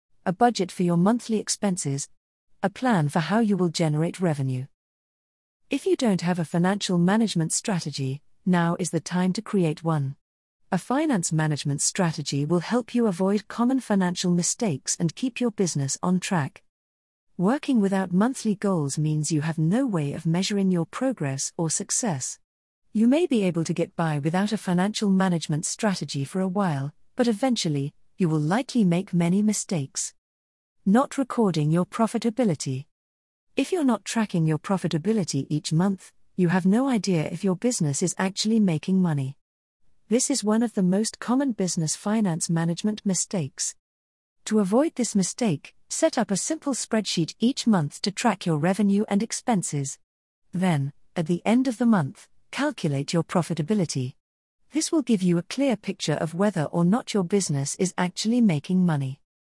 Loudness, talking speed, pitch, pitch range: -25 LUFS, 165 wpm, 185 Hz, 160-215 Hz